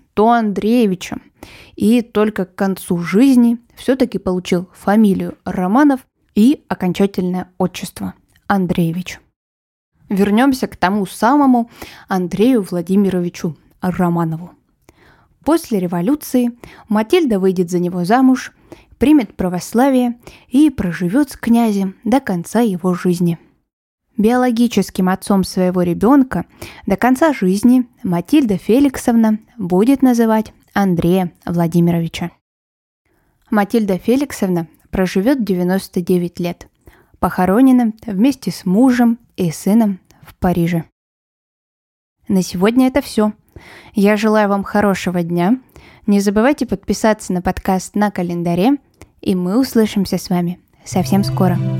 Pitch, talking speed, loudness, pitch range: 200 Hz, 100 wpm, -16 LUFS, 180-235 Hz